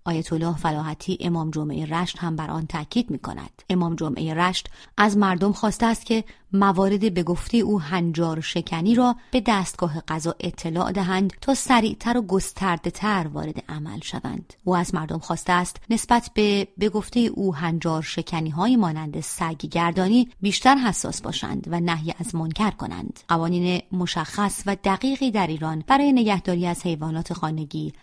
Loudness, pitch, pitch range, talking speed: -23 LUFS, 180 Hz, 165-210 Hz, 160 wpm